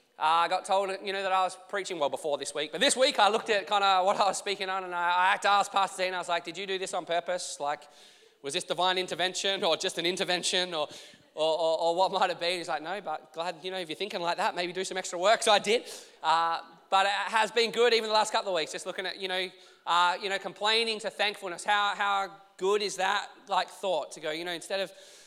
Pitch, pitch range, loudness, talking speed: 185 Hz, 175-200 Hz, -28 LUFS, 280 wpm